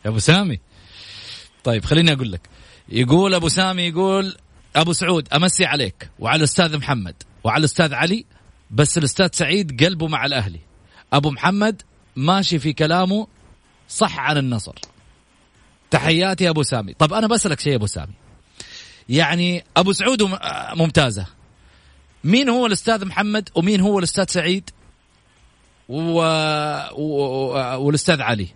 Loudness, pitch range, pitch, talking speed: -18 LUFS, 115-185 Hz, 155 Hz, 130 wpm